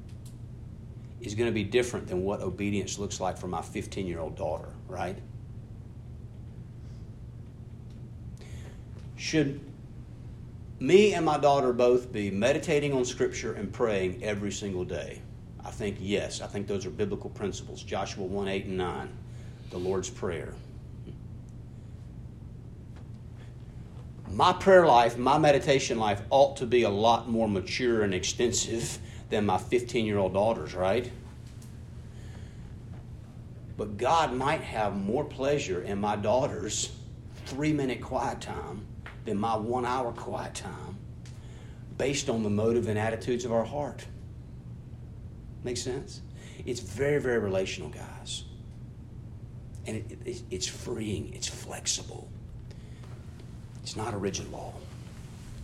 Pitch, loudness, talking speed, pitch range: 115 Hz, -29 LUFS, 125 wpm, 105-120 Hz